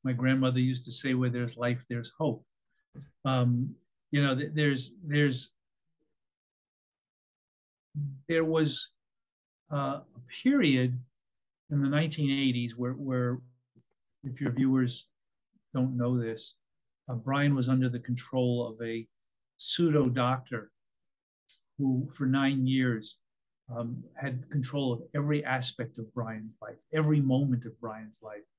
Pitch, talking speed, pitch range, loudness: 130 Hz, 125 wpm, 120-140 Hz, -30 LUFS